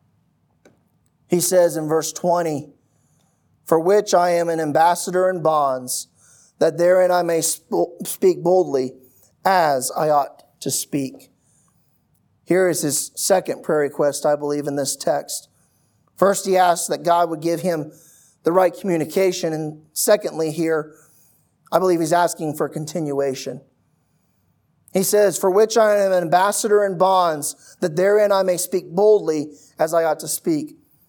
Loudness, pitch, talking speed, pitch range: -19 LUFS, 170 Hz, 150 wpm, 150-185 Hz